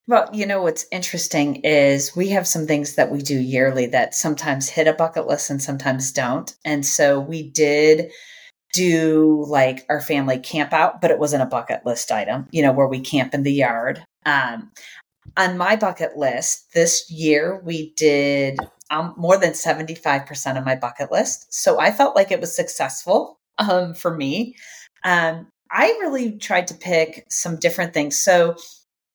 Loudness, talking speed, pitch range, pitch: -19 LUFS, 180 wpm, 140-175 Hz, 155 Hz